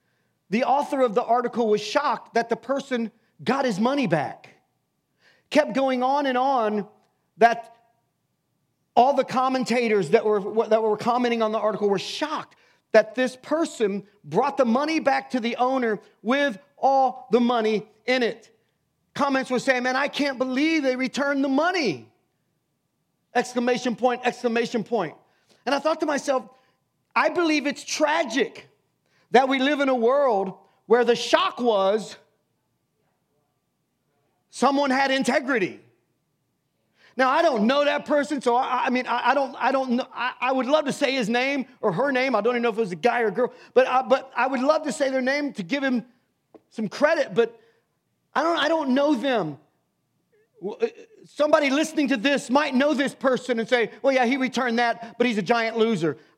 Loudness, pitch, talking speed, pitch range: -23 LUFS, 255 Hz, 180 wpm, 230-280 Hz